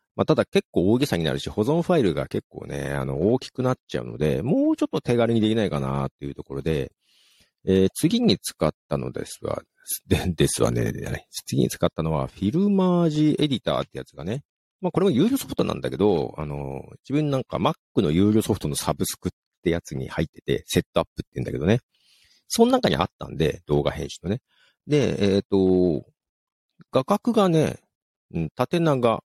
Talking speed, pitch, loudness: 375 characters per minute, 100 Hz, -24 LUFS